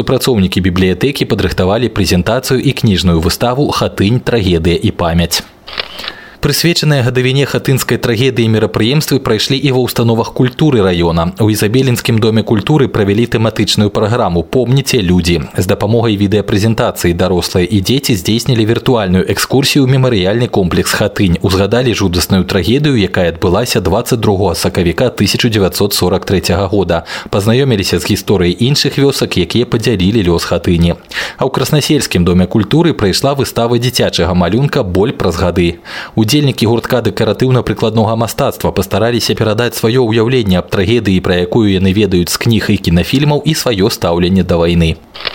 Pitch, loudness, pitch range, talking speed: 110 Hz, -12 LUFS, 95-125 Hz, 130 wpm